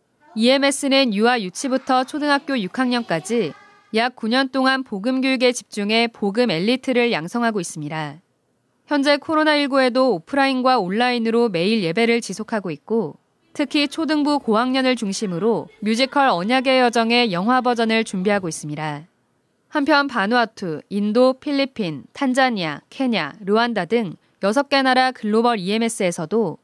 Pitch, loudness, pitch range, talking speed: 240 Hz, -20 LUFS, 210-265 Hz, 315 characters per minute